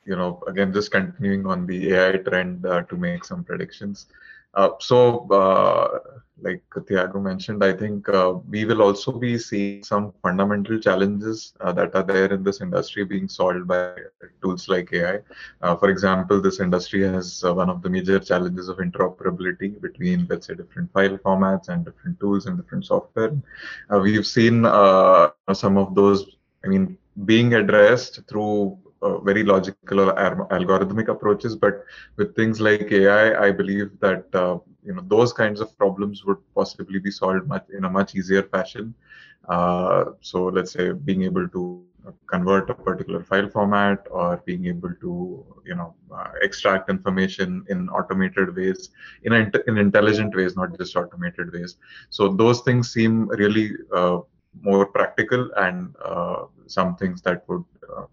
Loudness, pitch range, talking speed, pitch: -21 LUFS, 95-110 Hz, 165 wpm, 100 Hz